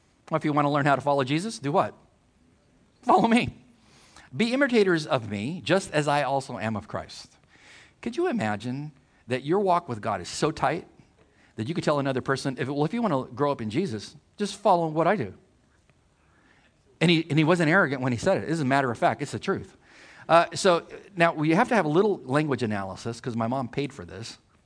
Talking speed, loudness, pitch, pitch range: 225 wpm, -25 LUFS, 145 Hz, 125-170 Hz